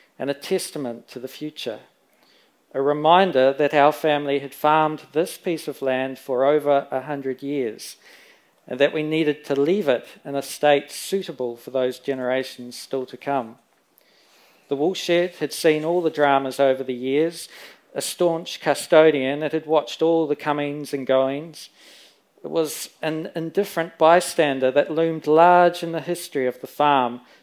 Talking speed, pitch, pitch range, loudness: 160 wpm, 145 Hz, 135-160 Hz, -22 LUFS